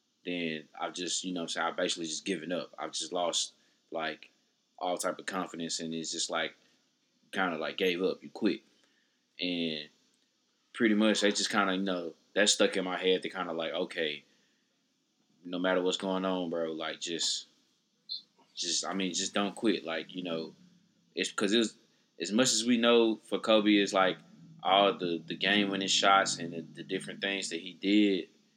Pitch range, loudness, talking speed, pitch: 85-100 Hz, -31 LUFS, 195 wpm, 95 Hz